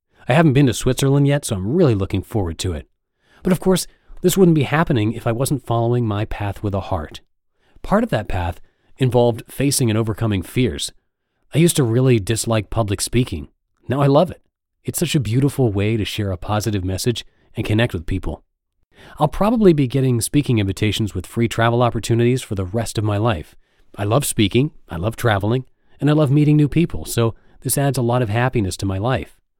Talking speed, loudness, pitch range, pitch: 205 wpm, -19 LUFS, 100-135 Hz, 115 Hz